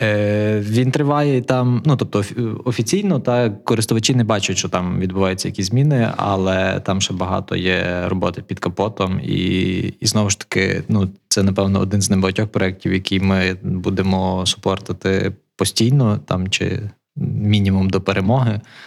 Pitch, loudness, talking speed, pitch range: 100 Hz, -18 LUFS, 145 wpm, 95-115 Hz